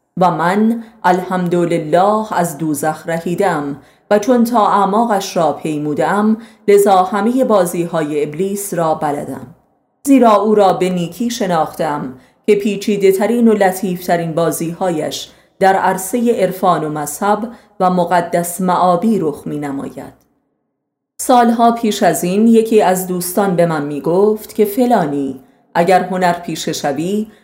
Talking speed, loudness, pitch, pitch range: 130 wpm, -15 LUFS, 185 Hz, 170-210 Hz